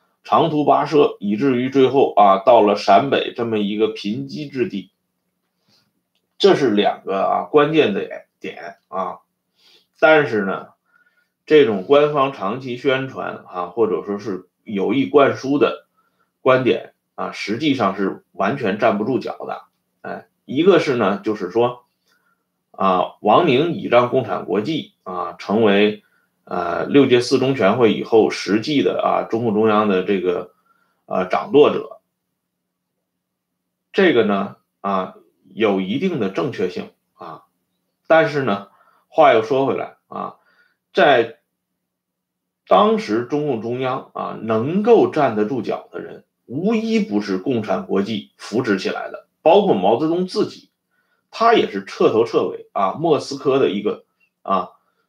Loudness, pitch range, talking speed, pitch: -18 LUFS, 105-160 Hz, 200 characters per minute, 130 Hz